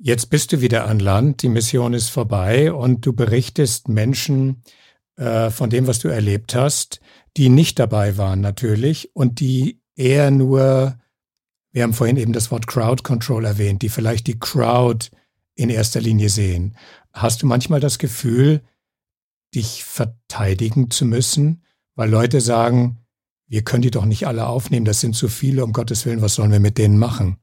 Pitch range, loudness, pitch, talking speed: 110-130 Hz, -18 LUFS, 120 Hz, 175 wpm